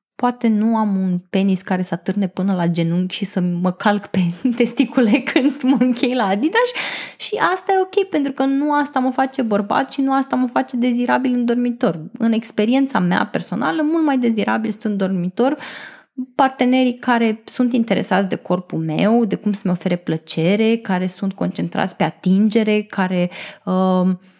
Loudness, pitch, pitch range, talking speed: -18 LUFS, 220 Hz, 185-255 Hz, 170 wpm